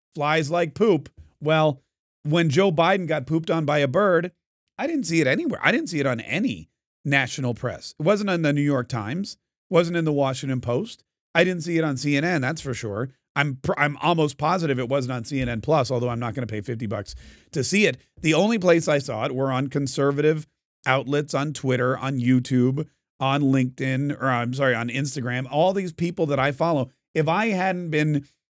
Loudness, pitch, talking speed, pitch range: -23 LUFS, 145 Hz, 205 wpm, 130-165 Hz